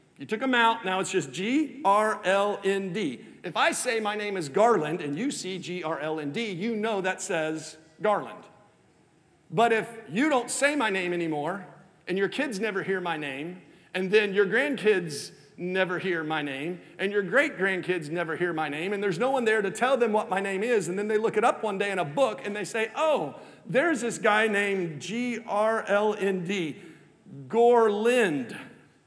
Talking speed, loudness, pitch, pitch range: 180 wpm, -27 LUFS, 200 Hz, 175-225 Hz